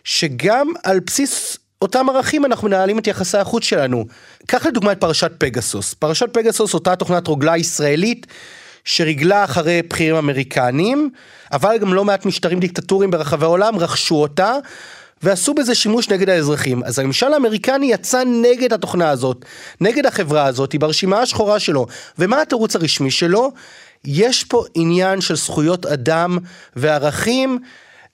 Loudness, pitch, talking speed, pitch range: -16 LUFS, 185 Hz, 140 wpm, 155-230 Hz